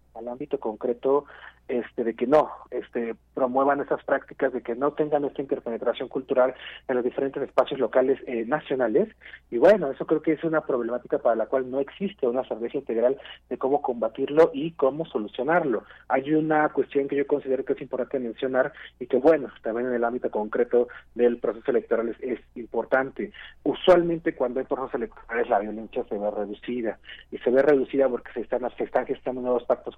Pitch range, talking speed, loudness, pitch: 120-145 Hz, 185 wpm, -26 LUFS, 135 Hz